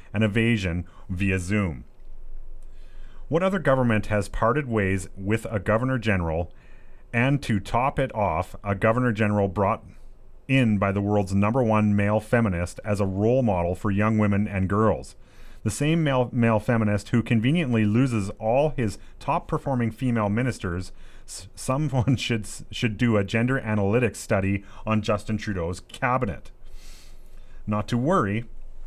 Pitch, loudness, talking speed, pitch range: 110 Hz, -24 LUFS, 150 wpm, 100-120 Hz